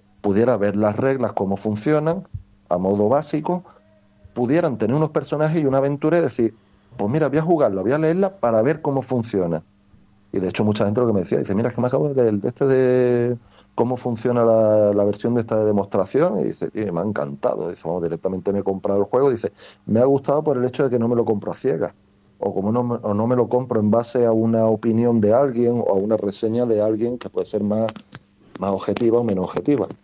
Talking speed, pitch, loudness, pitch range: 230 wpm, 115 Hz, -20 LUFS, 105-130 Hz